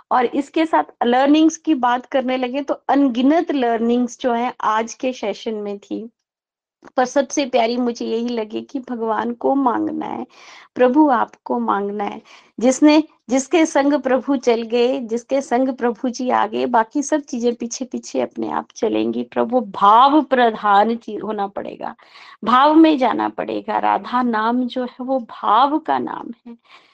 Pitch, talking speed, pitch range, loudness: 250 Hz, 155 wpm, 225-275 Hz, -18 LUFS